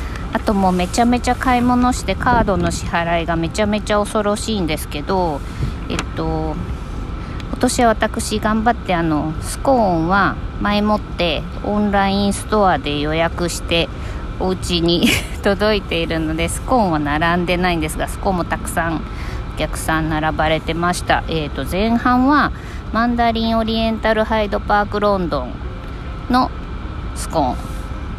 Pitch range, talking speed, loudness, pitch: 165-225 Hz, 315 characters per minute, -18 LUFS, 200 Hz